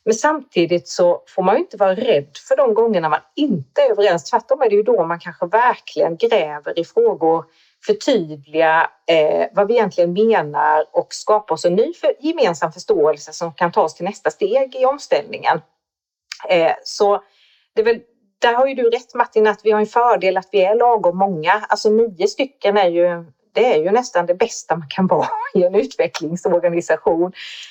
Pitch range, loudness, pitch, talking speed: 175-265 Hz, -17 LUFS, 210 Hz, 185 wpm